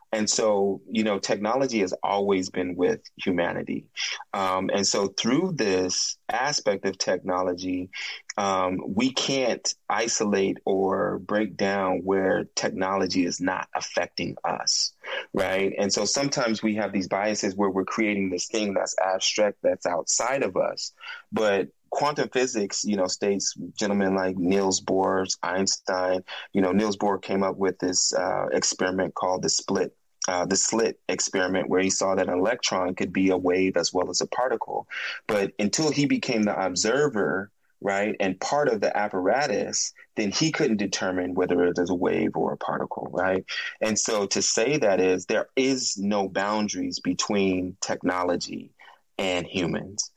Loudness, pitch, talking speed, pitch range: -25 LUFS, 95 Hz, 160 wpm, 90-105 Hz